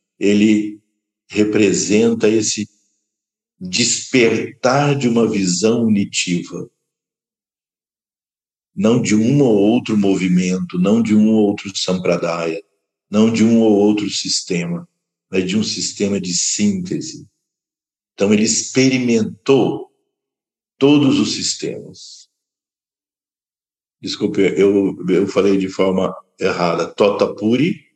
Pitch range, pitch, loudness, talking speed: 100-120 Hz, 105 Hz, -16 LUFS, 100 wpm